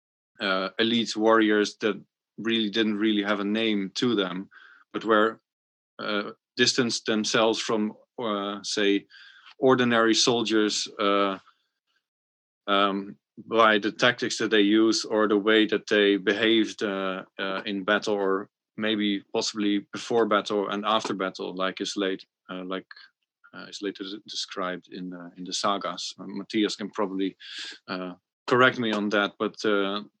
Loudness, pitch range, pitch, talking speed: -25 LUFS, 95-110 Hz, 105 Hz, 145 wpm